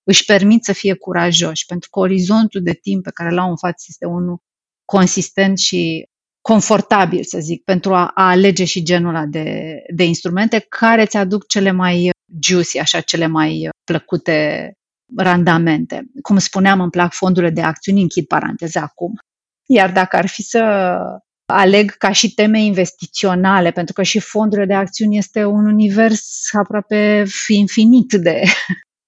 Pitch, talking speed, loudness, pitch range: 190 Hz, 155 wpm, -14 LUFS, 175-210 Hz